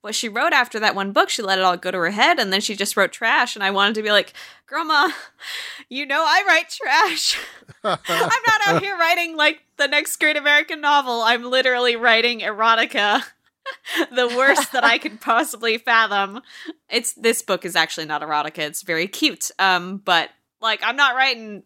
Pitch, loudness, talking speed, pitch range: 235 Hz, -18 LUFS, 200 wpm, 195-290 Hz